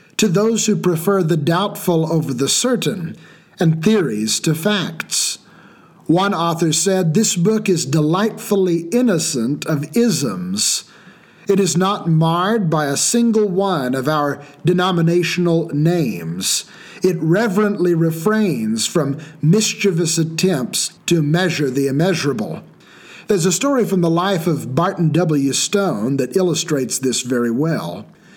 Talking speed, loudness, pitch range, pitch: 125 wpm, -17 LUFS, 160-200 Hz, 175 Hz